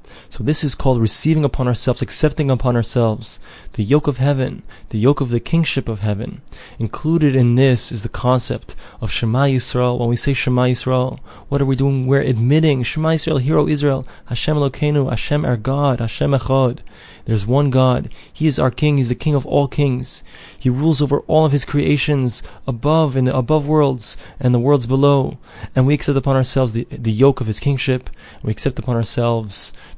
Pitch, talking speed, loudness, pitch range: 130 Hz, 190 wpm, -17 LUFS, 120-145 Hz